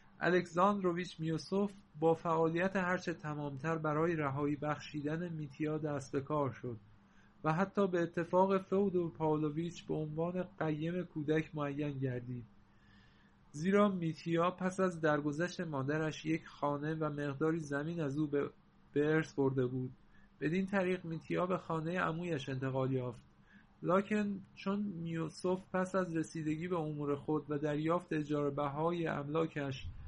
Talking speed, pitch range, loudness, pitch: 130 wpm, 145-175 Hz, -36 LUFS, 160 Hz